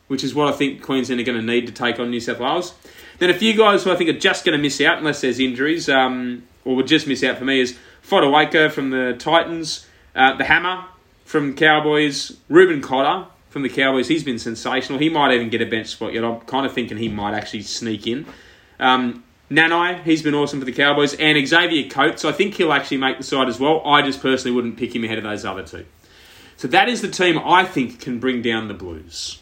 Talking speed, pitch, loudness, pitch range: 240 wpm, 135 Hz, -18 LUFS, 120-155 Hz